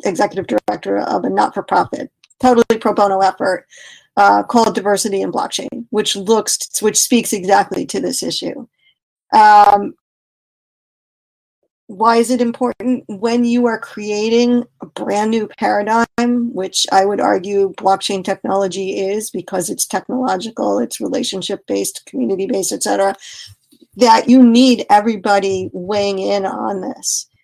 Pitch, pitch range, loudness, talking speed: 215 Hz, 195-240 Hz, -15 LUFS, 130 wpm